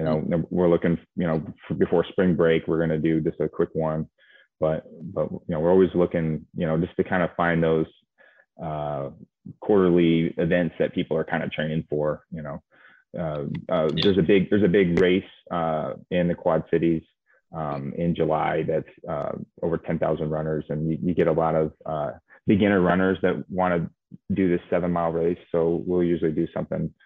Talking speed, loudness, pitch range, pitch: 195 wpm, -24 LUFS, 80-90 Hz, 85 Hz